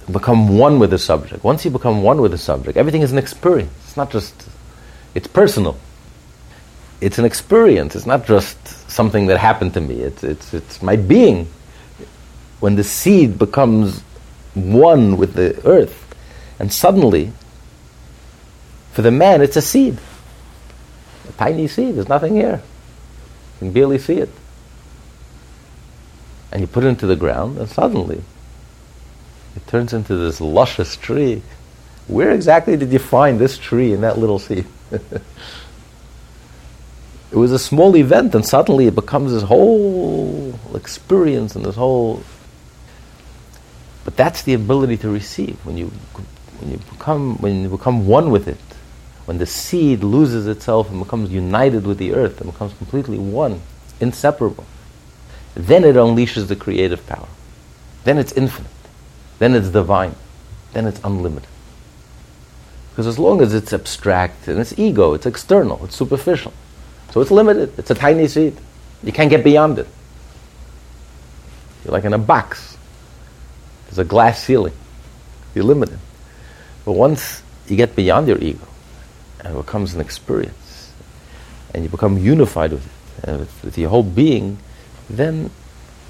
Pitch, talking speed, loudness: 95 Hz, 150 wpm, -15 LUFS